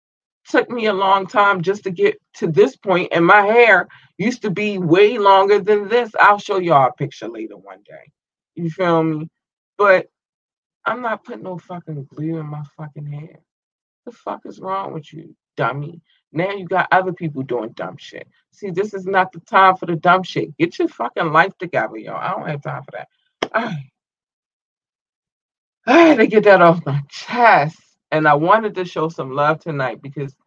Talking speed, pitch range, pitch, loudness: 190 wpm, 155-205 Hz, 185 Hz, -16 LUFS